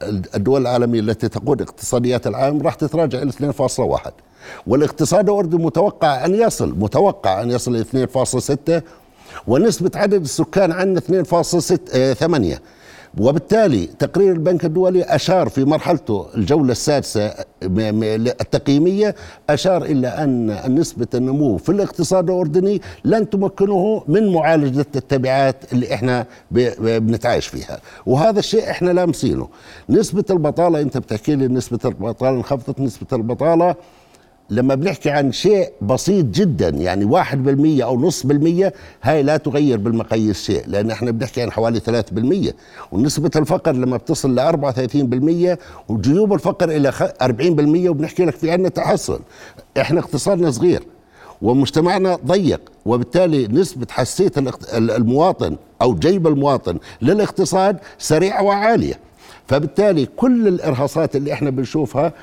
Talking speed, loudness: 125 wpm, -17 LUFS